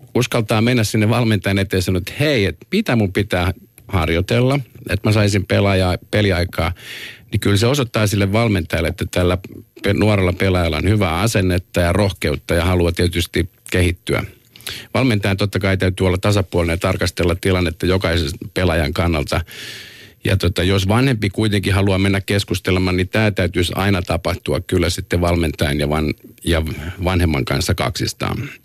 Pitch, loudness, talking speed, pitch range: 95 Hz, -18 LUFS, 150 wpm, 85-105 Hz